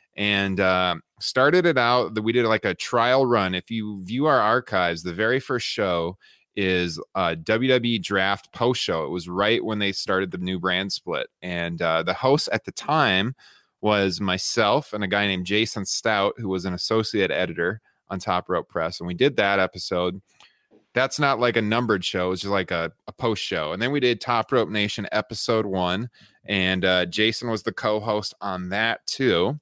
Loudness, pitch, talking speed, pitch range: -23 LUFS, 100 Hz, 195 wpm, 90-115 Hz